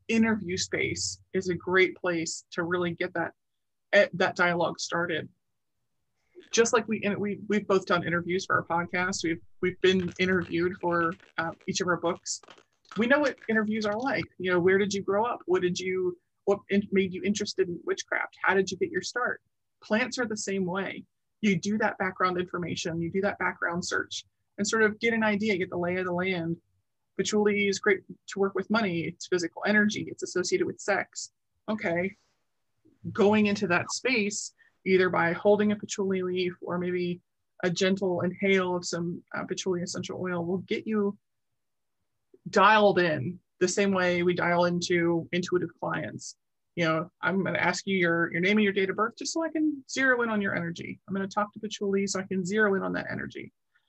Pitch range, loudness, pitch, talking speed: 180-210 Hz, -28 LUFS, 190 Hz, 195 wpm